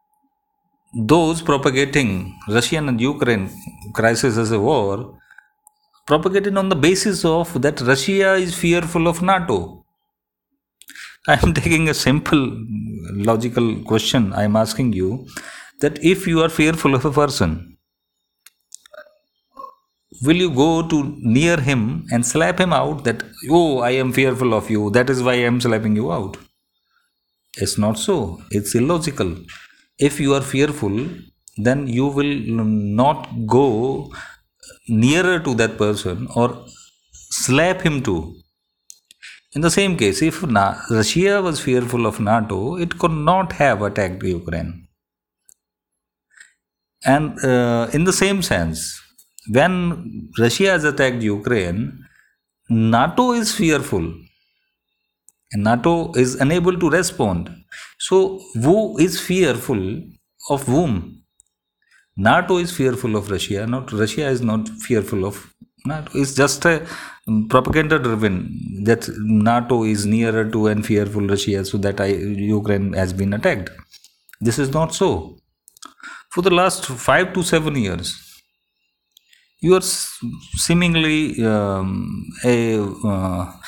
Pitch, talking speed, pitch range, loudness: 125 Hz, 125 wpm, 105-165 Hz, -18 LUFS